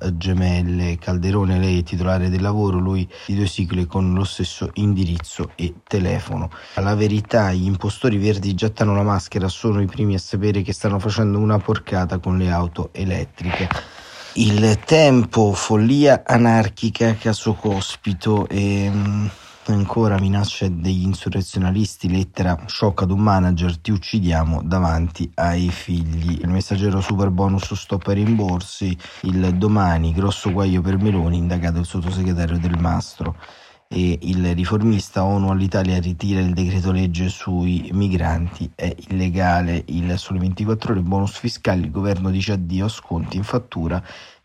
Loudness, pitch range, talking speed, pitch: -20 LUFS, 90-105 Hz, 145 wpm, 95 Hz